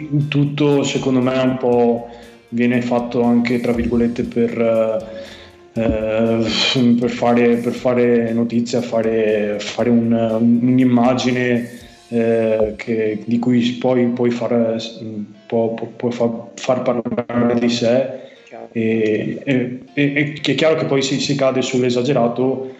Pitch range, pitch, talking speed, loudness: 115-125 Hz, 120 Hz, 115 wpm, -17 LUFS